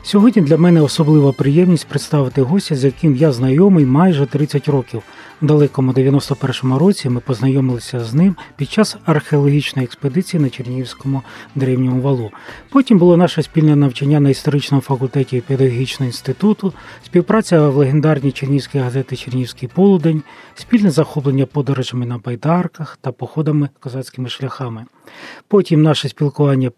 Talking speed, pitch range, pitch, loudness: 135 wpm, 130-155 Hz, 140 Hz, -15 LUFS